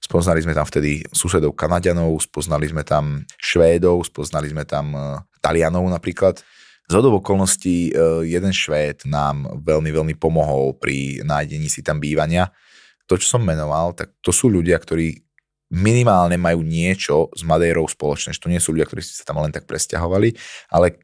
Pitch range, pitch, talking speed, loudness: 75-90 Hz, 80 Hz, 155 wpm, -19 LUFS